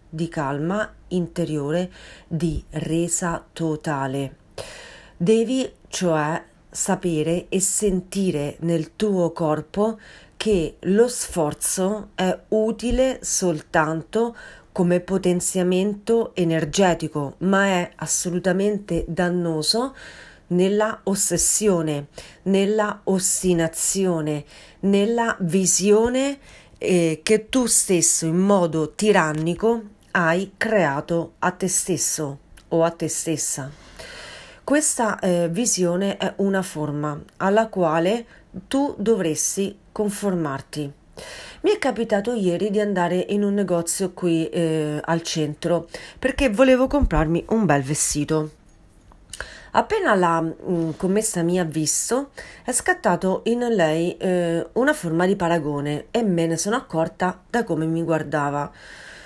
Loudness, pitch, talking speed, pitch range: -21 LUFS, 180 Hz, 105 wpm, 160-210 Hz